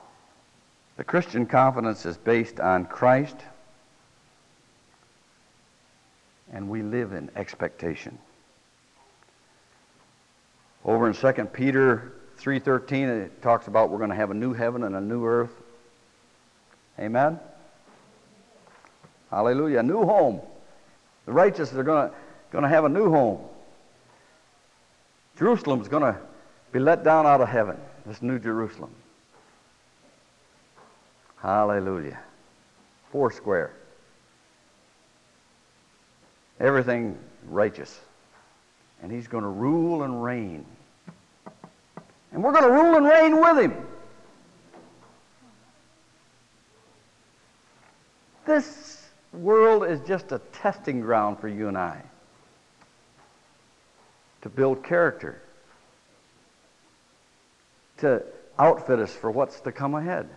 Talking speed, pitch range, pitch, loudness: 100 wpm, 110-155 Hz, 125 Hz, -23 LUFS